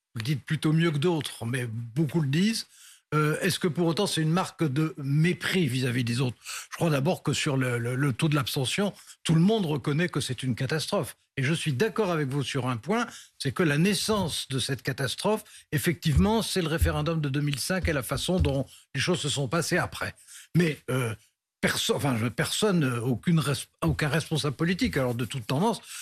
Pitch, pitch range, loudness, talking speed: 150 Hz, 135-175 Hz, -27 LUFS, 195 wpm